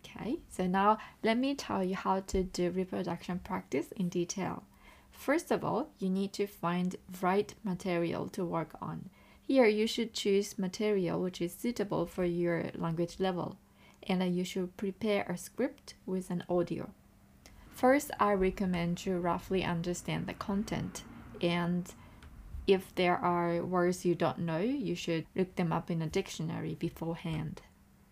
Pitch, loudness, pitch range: 185 Hz, -33 LUFS, 175-200 Hz